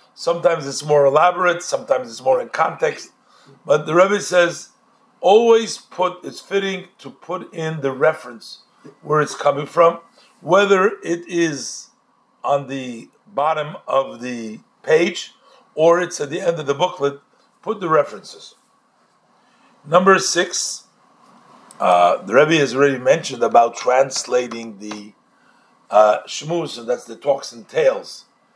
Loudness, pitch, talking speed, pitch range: -18 LUFS, 165 Hz, 140 wpm, 140-190 Hz